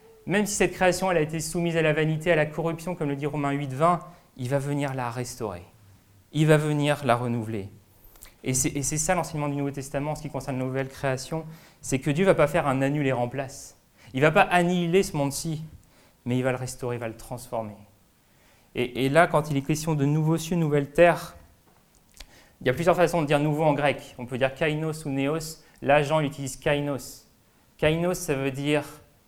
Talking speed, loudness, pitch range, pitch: 215 wpm, -25 LUFS, 130-160 Hz, 145 Hz